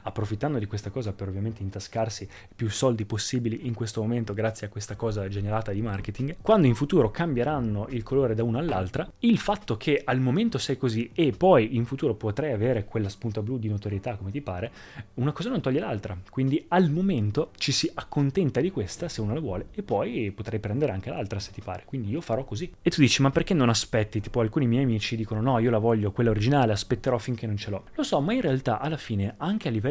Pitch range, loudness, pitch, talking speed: 105-135 Hz, -27 LUFS, 115 Hz, 225 wpm